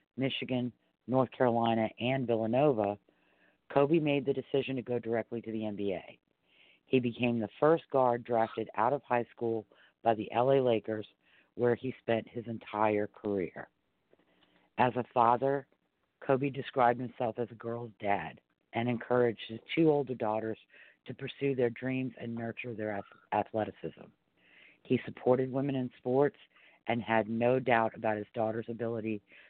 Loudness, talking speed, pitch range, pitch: -32 LUFS, 145 wpm, 110-130 Hz, 120 Hz